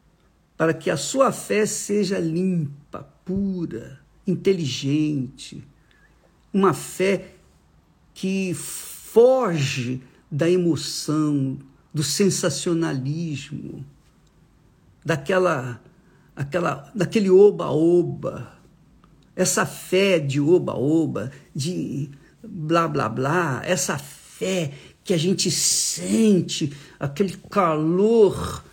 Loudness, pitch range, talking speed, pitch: -22 LUFS, 145-185 Hz, 80 wpm, 170 Hz